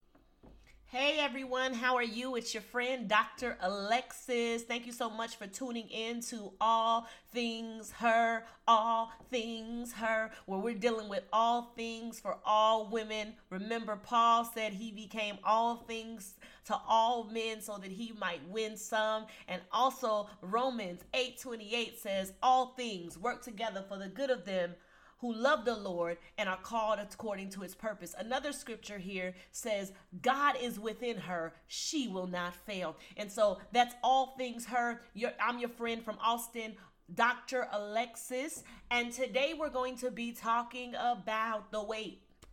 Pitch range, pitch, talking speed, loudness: 210-240 Hz, 230 Hz, 155 wpm, -35 LUFS